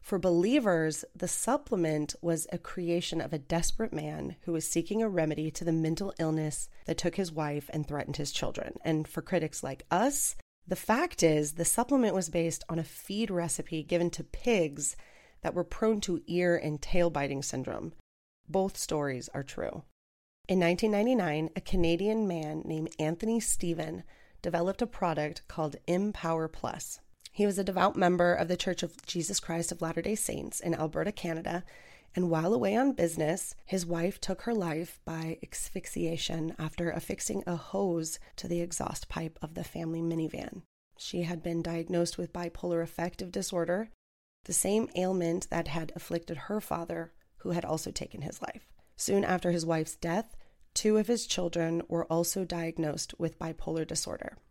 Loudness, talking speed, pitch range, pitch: -32 LUFS, 170 wpm, 160-185 Hz, 170 Hz